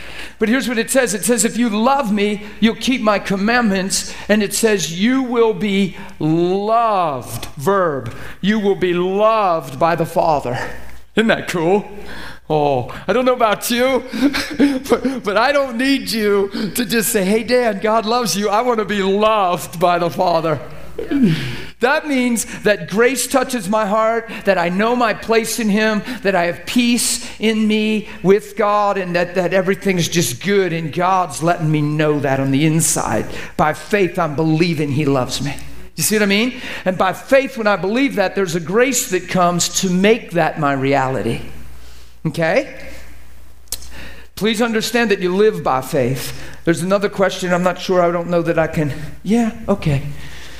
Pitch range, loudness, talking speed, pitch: 165-225 Hz, -17 LUFS, 175 wpm, 195 Hz